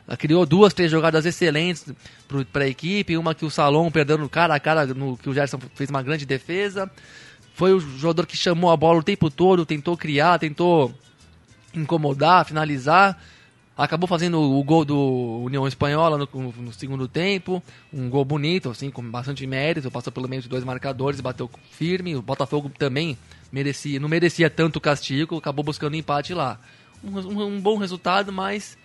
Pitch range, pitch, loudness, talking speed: 135-170 Hz, 150 Hz, -22 LUFS, 175 wpm